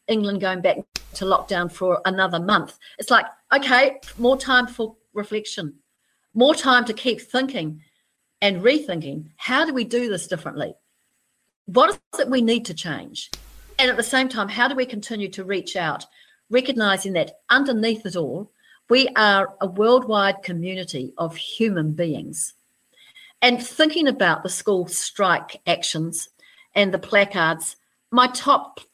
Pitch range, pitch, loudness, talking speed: 180-250 Hz, 210 Hz, -21 LUFS, 150 wpm